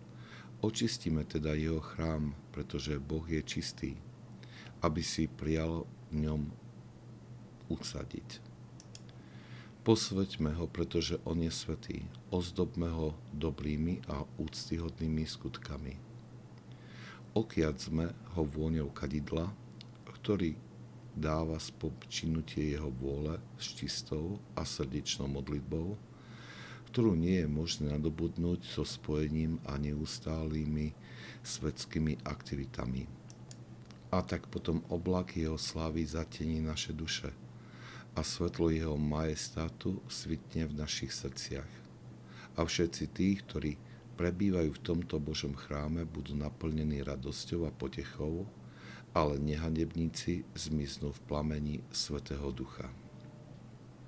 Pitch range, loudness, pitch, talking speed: 75-85 Hz, -37 LUFS, 80 Hz, 100 wpm